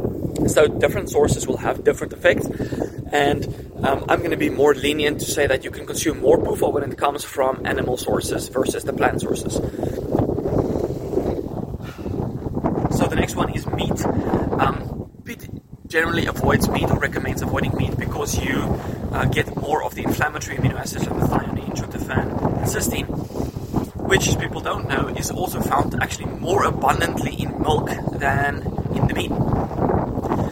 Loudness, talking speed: -22 LUFS, 155 wpm